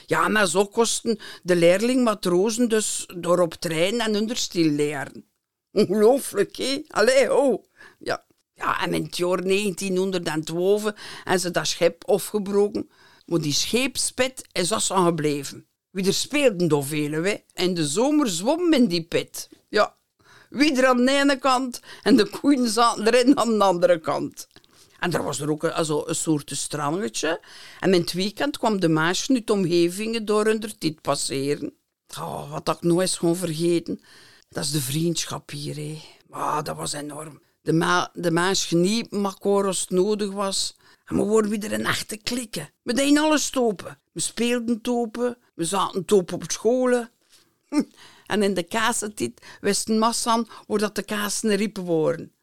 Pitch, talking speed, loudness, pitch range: 195 Hz, 165 wpm, -23 LUFS, 170-230 Hz